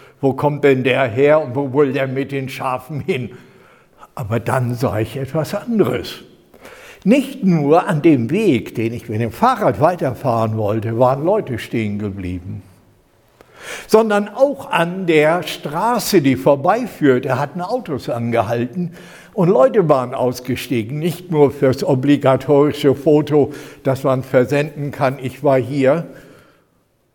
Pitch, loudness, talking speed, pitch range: 140 Hz, -17 LUFS, 135 wpm, 125-160 Hz